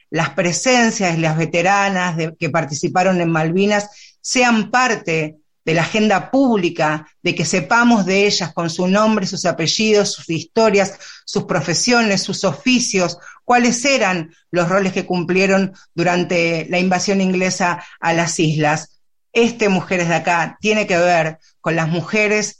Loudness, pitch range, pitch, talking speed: -17 LUFS, 165-205 Hz, 180 Hz, 145 wpm